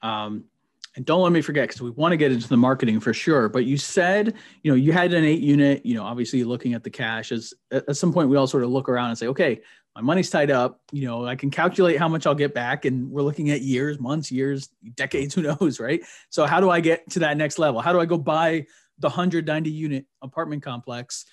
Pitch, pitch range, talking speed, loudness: 140 Hz, 125-160 Hz, 255 wpm, -22 LUFS